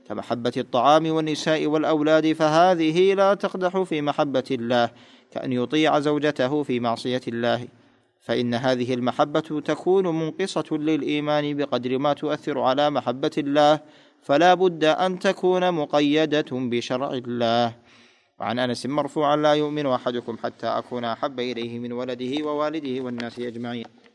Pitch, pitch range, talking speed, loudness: 145 Hz, 125-155 Hz, 125 wpm, -23 LUFS